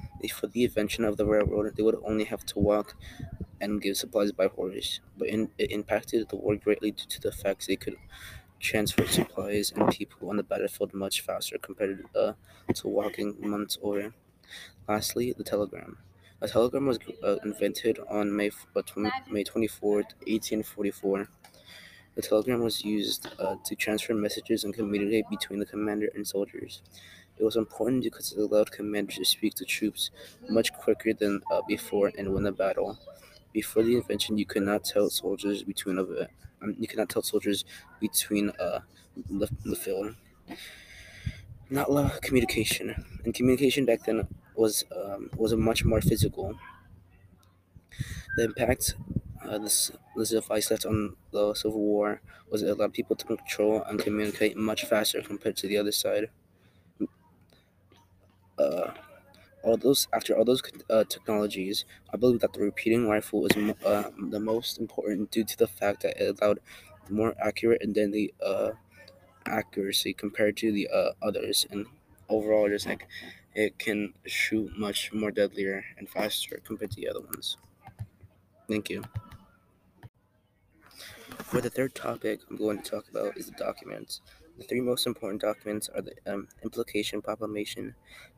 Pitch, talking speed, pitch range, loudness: 105 Hz, 160 wpm, 100-110 Hz, -29 LUFS